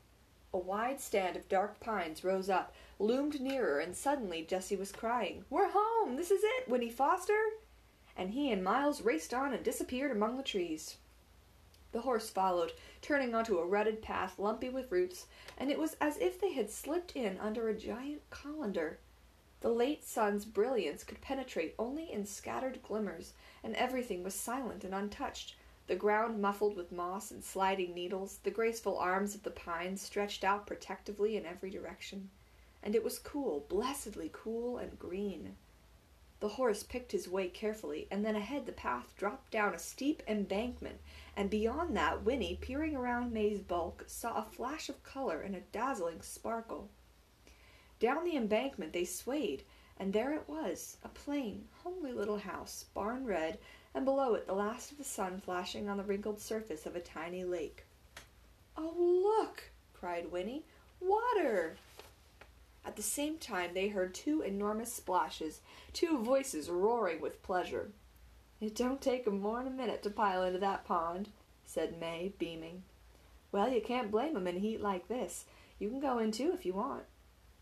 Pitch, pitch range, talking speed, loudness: 215 Hz, 195-275 Hz, 170 wpm, -37 LUFS